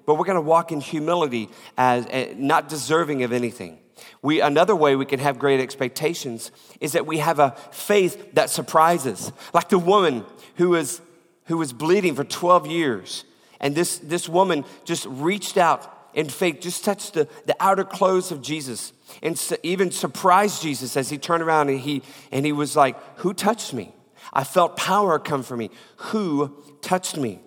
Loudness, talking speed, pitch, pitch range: -22 LUFS, 185 wpm, 155 Hz, 140-175 Hz